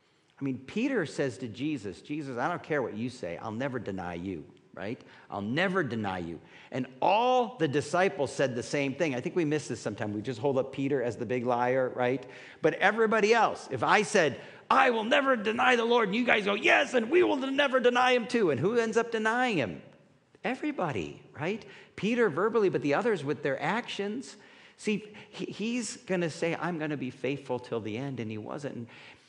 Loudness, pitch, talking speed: -29 LUFS, 160 Hz, 205 wpm